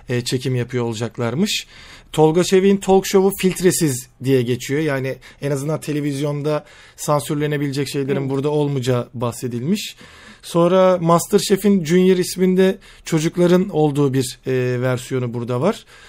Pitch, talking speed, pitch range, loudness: 150 Hz, 110 wpm, 130-180 Hz, -19 LUFS